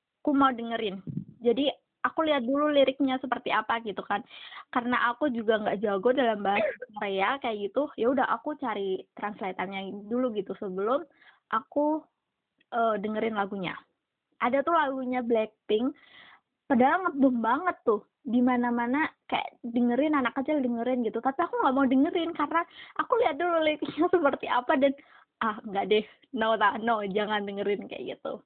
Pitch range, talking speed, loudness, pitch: 220-295 Hz, 155 wpm, -28 LUFS, 250 Hz